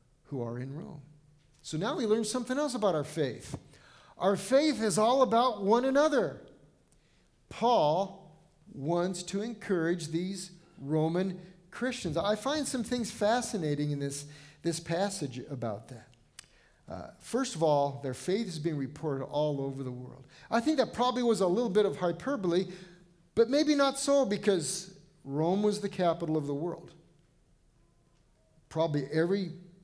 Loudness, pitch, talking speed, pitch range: -30 LUFS, 180 Hz, 150 wpm, 150-215 Hz